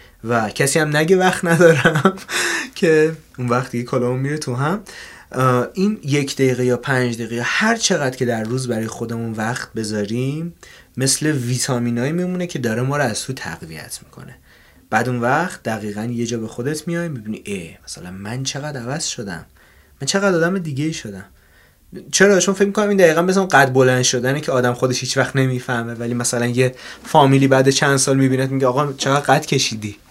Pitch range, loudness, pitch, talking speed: 120-155 Hz, -18 LUFS, 130 Hz, 175 wpm